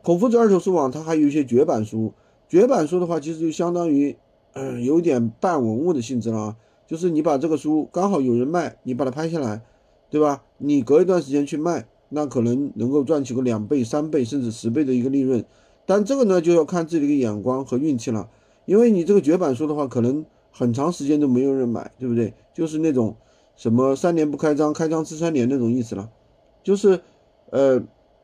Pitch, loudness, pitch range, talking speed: 145 Hz, -21 LUFS, 120-165 Hz, 325 characters per minute